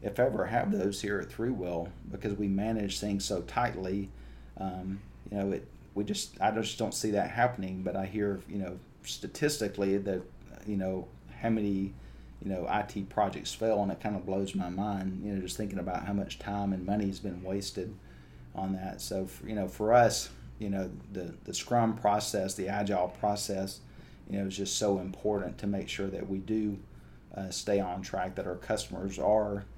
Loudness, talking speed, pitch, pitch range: -33 LUFS, 195 wpm, 100 Hz, 95-105 Hz